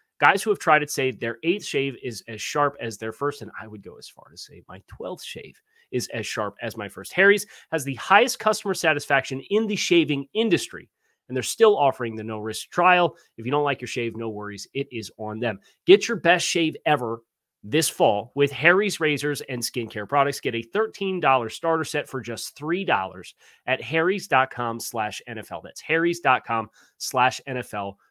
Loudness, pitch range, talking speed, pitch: -23 LUFS, 115-170 Hz, 190 wpm, 140 Hz